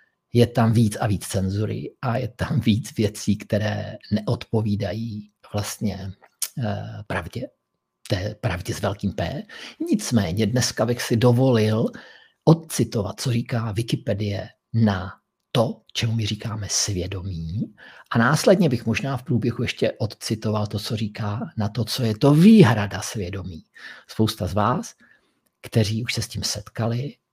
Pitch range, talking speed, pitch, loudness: 105-120 Hz, 135 wpm, 110 Hz, -23 LUFS